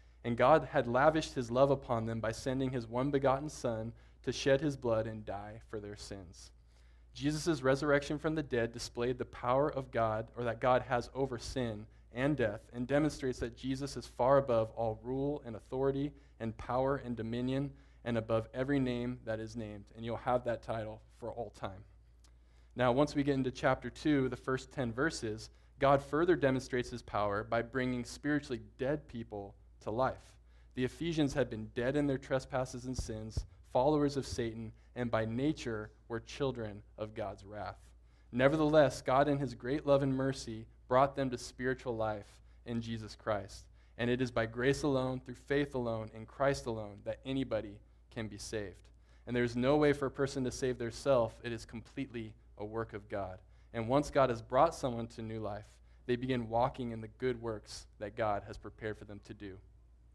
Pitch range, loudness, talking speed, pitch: 110-135 Hz, -35 LUFS, 190 wpm, 120 Hz